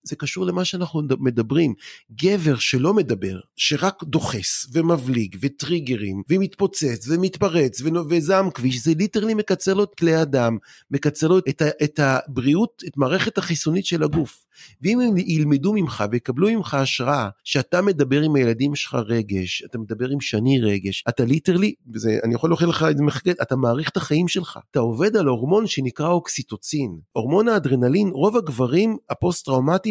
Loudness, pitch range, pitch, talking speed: -21 LUFS, 125-180 Hz, 150 Hz, 155 wpm